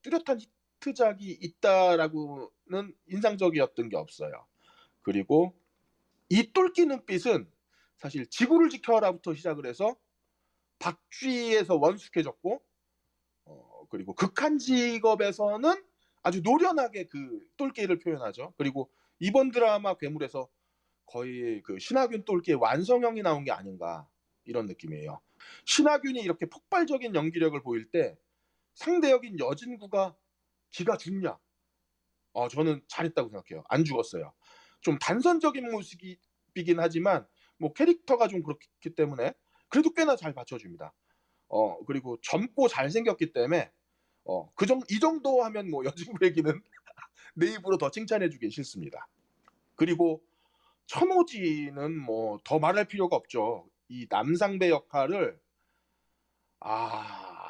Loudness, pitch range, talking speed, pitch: -29 LUFS, 155-260 Hz, 275 characters per minute, 190 Hz